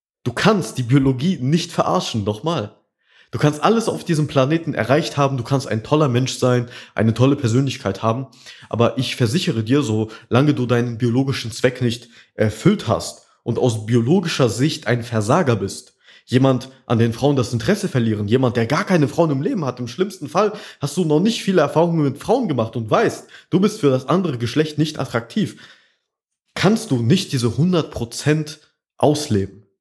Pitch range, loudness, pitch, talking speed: 120-160 Hz, -19 LUFS, 130 Hz, 180 wpm